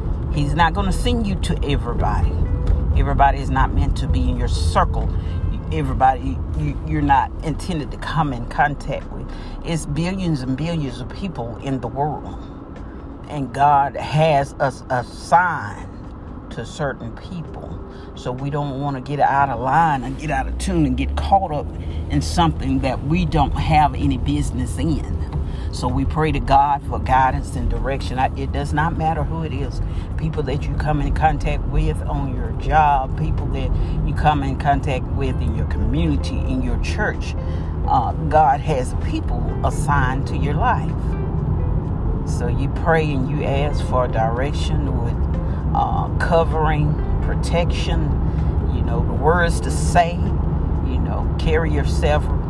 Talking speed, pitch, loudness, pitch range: 160 wpm, 80 Hz, -20 LUFS, 75-125 Hz